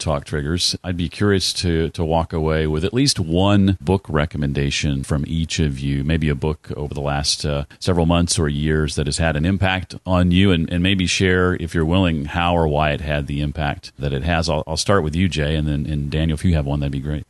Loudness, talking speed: -20 LUFS, 245 wpm